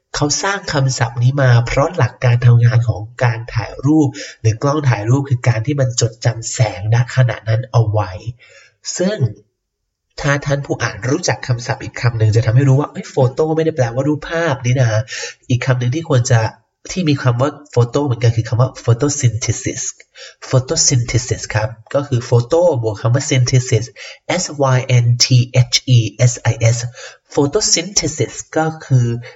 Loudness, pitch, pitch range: -16 LUFS, 125 Hz, 115-140 Hz